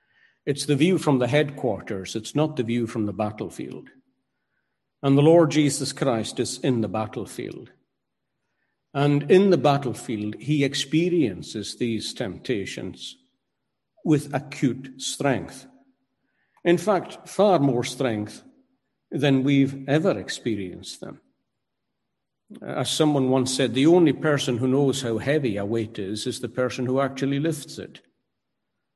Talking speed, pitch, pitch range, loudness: 135 wpm, 135 Hz, 120-155 Hz, -23 LUFS